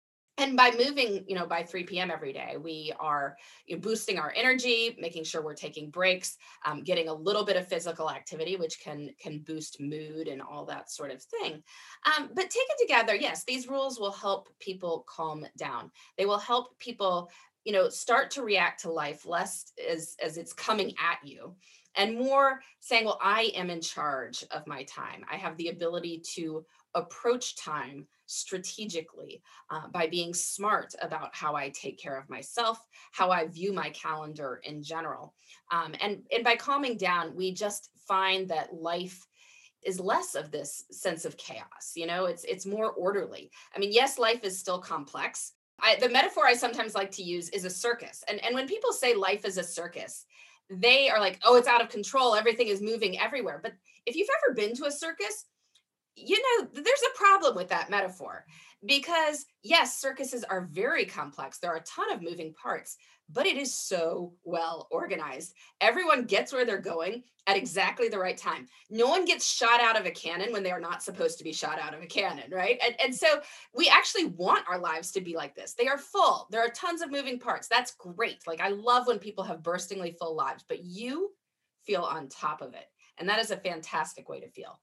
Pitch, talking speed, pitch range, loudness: 205 Hz, 200 wpm, 175-260 Hz, -29 LUFS